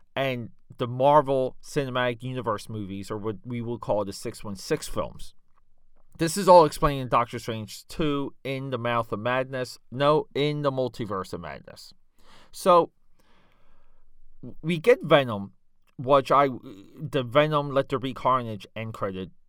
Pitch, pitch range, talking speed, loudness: 130 Hz, 115-145 Hz, 145 wpm, -25 LUFS